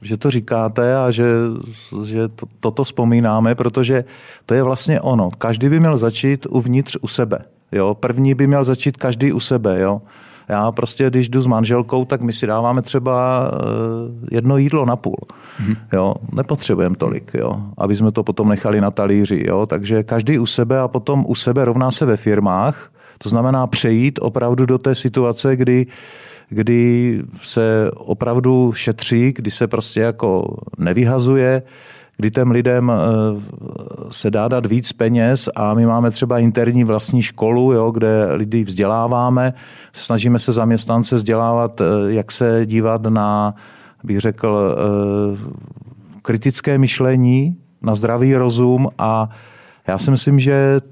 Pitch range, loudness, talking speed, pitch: 110-130 Hz, -16 LUFS, 145 wpm, 120 Hz